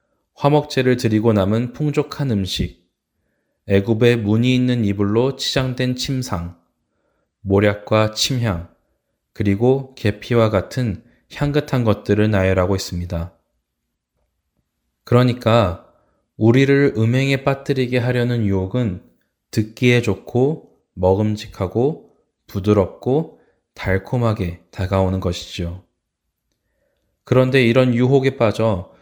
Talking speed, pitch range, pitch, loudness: 230 characters per minute, 95-125 Hz, 110 Hz, -18 LUFS